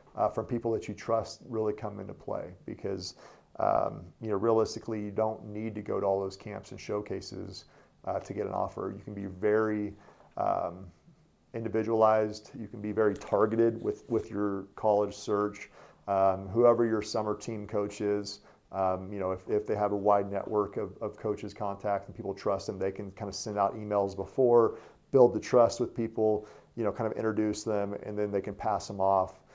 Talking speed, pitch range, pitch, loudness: 200 wpm, 100-110 Hz, 105 Hz, -31 LUFS